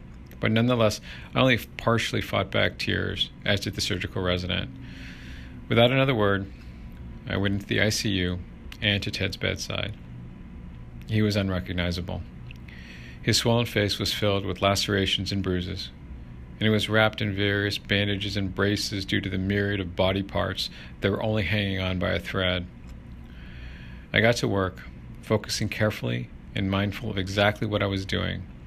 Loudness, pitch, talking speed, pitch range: -26 LUFS, 95 Hz, 155 wpm, 65-105 Hz